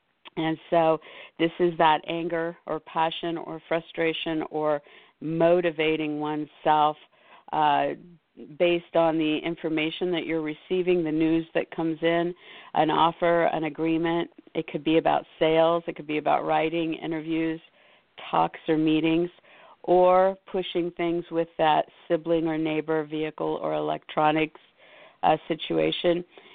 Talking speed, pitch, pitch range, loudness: 130 wpm, 165 Hz, 155-170 Hz, -26 LUFS